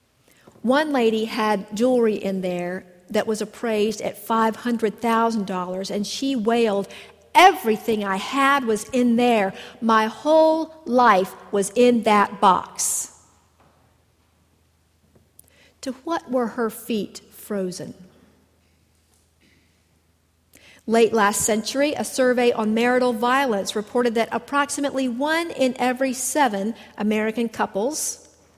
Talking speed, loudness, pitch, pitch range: 105 wpm, -21 LUFS, 220 Hz, 190-245 Hz